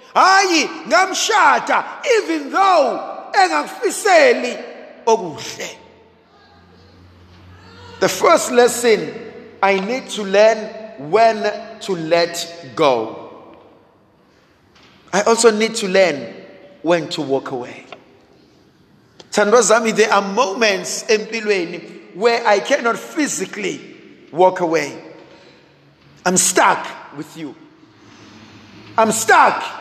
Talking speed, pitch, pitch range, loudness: 85 wpm, 215 Hz, 170-240 Hz, -16 LUFS